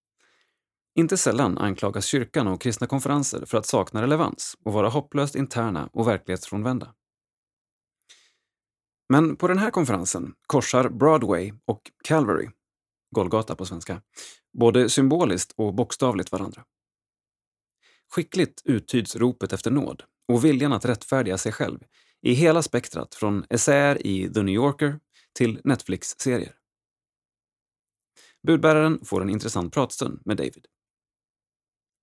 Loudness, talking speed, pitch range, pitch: -24 LUFS, 120 wpm, 100-140 Hz, 115 Hz